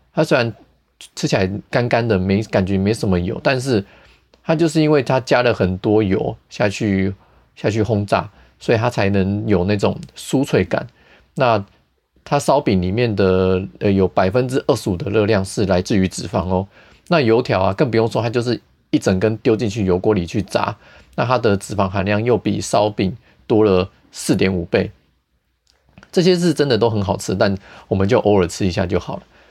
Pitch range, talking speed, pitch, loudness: 95-115 Hz, 265 characters per minute, 100 Hz, -18 LUFS